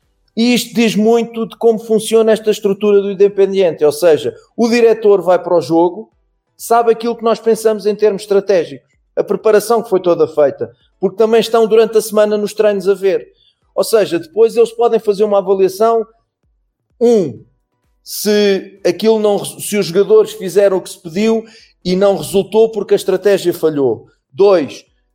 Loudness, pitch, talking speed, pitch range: -13 LUFS, 210 Hz, 170 wpm, 195-225 Hz